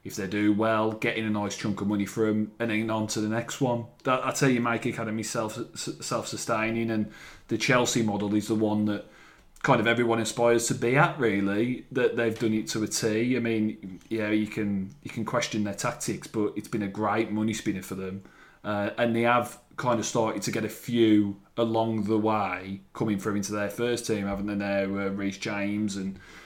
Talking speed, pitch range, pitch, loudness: 215 wpm, 105-115 Hz, 110 Hz, -27 LUFS